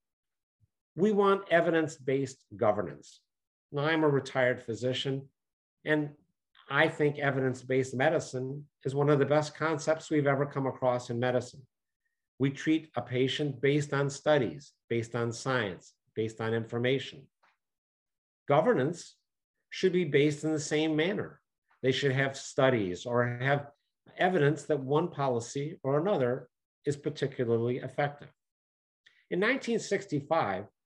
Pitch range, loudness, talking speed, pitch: 130-155 Hz, -30 LUFS, 130 wpm, 140 Hz